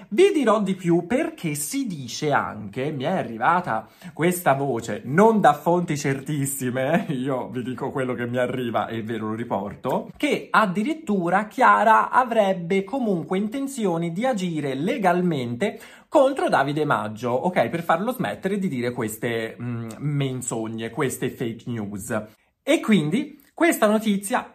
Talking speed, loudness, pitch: 135 wpm, -23 LUFS, 160 Hz